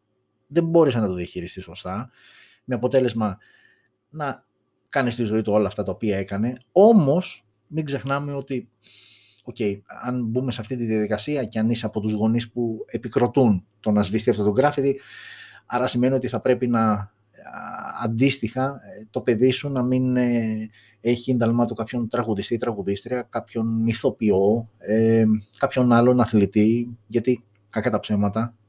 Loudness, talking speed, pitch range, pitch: -23 LUFS, 150 wpm, 105-125 Hz, 115 Hz